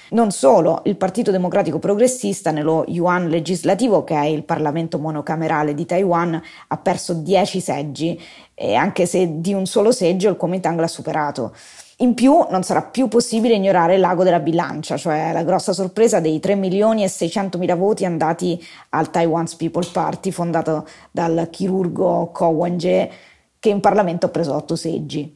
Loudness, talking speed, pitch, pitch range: -18 LUFS, 165 wpm, 175 Hz, 165-190 Hz